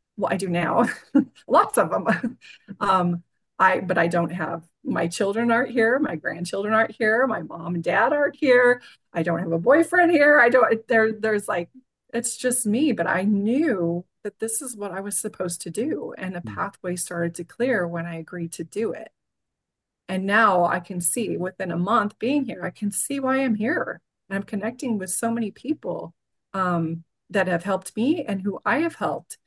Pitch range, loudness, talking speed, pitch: 175-240 Hz, -23 LUFS, 200 wpm, 205 Hz